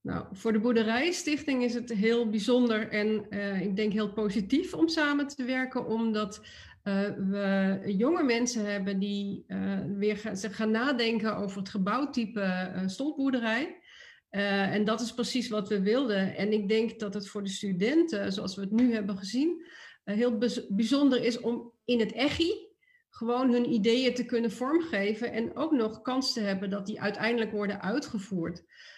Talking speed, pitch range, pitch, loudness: 175 wpm, 205-250 Hz, 225 Hz, -29 LUFS